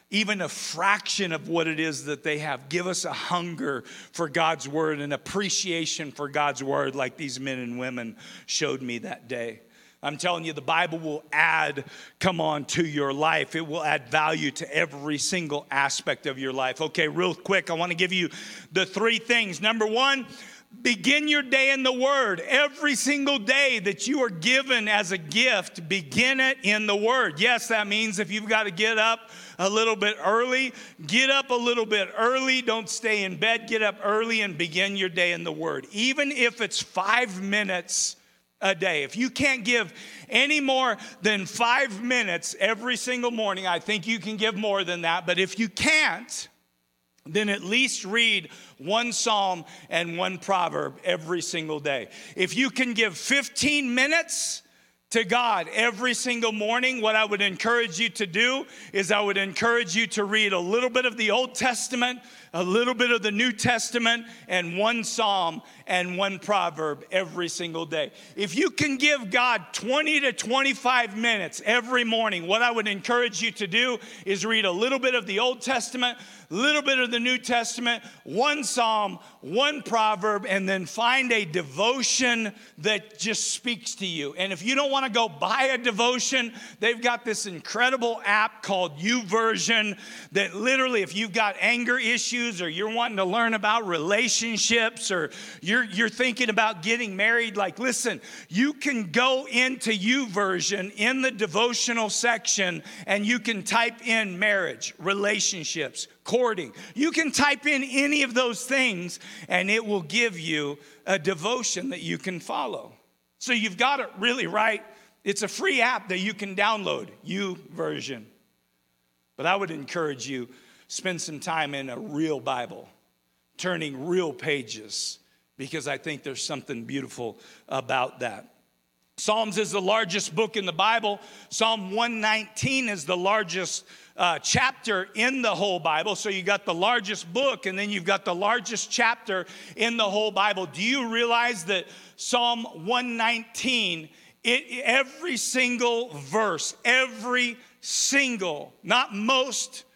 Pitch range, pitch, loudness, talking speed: 180-240 Hz, 215 Hz, -24 LUFS, 170 wpm